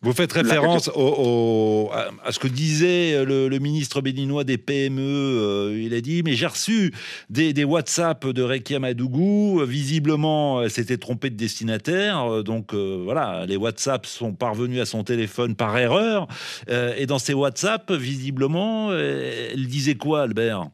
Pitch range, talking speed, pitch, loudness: 120-155 Hz, 165 wpm, 135 Hz, -22 LUFS